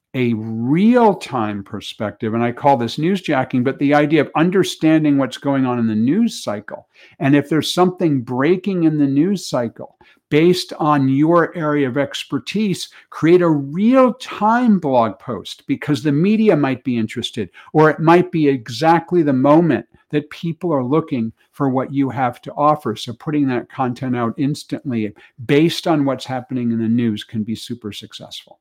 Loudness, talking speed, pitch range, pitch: -17 LUFS, 170 wpm, 125-165 Hz, 145 Hz